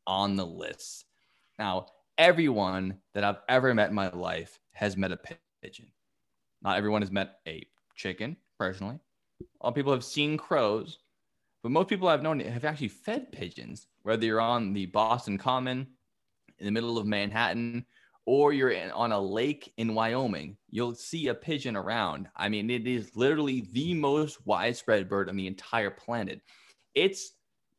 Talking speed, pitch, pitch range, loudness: 160 wpm, 115 Hz, 100-130 Hz, -29 LUFS